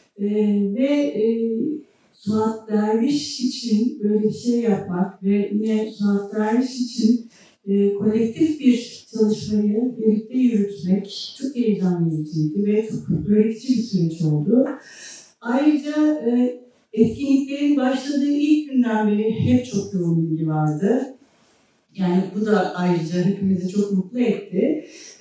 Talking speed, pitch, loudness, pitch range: 120 wpm, 215 Hz, -21 LUFS, 200-250 Hz